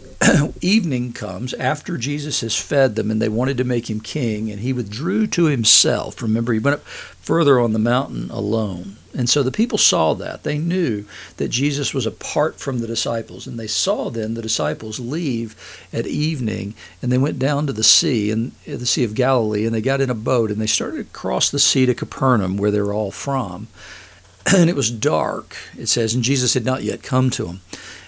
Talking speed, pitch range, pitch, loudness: 205 wpm, 110-135 Hz, 120 Hz, -19 LUFS